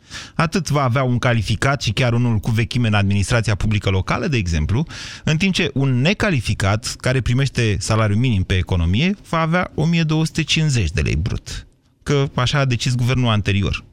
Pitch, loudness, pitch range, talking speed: 120 Hz, -19 LUFS, 105-145 Hz, 170 wpm